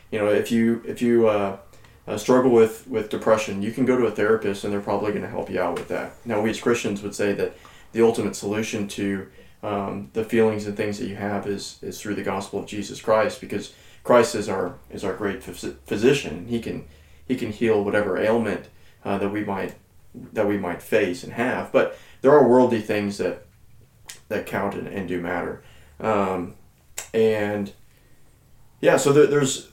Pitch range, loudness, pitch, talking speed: 100-115 Hz, -23 LUFS, 105 Hz, 200 wpm